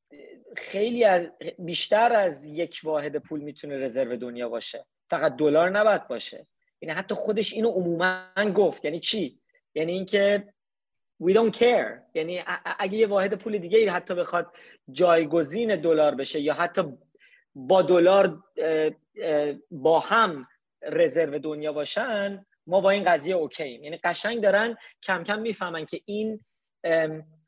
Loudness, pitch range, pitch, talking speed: -25 LUFS, 155-210 Hz, 180 Hz, 135 wpm